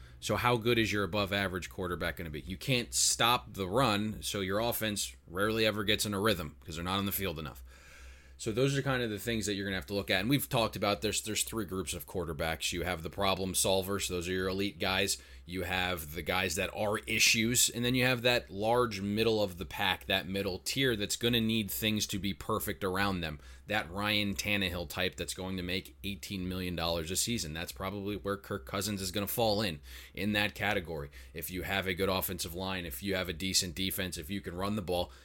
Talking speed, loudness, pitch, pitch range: 240 wpm, -32 LUFS, 95 Hz, 90-105 Hz